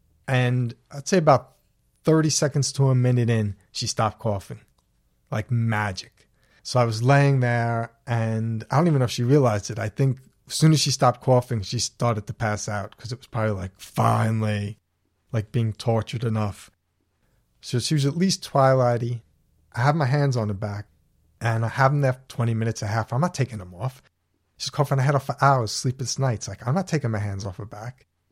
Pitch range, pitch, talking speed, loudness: 105-135 Hz, 120 Hz, 210 wpm, -23 LUFS